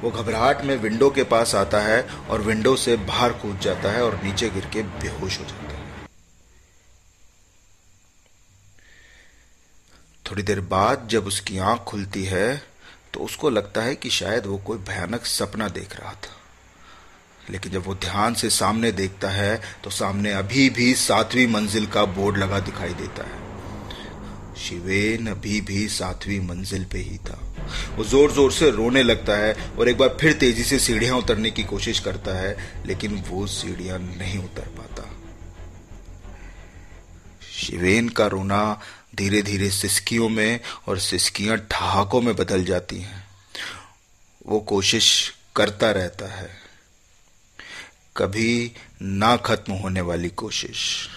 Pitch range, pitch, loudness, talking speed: 95-110 Hz, 100 Hz, -22 LUFS, 145 wpm